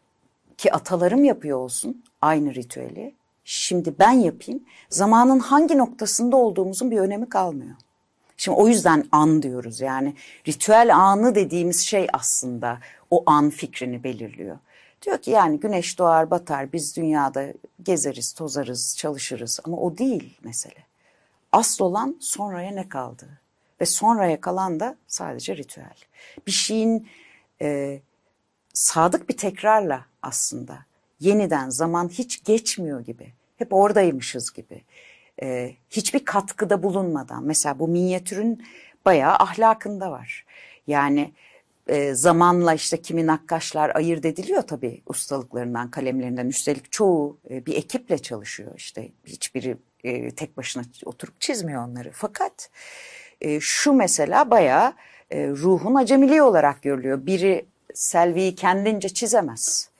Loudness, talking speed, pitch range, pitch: -21 LUFS, 120 wpm, 140-210 Hz, 170 Hz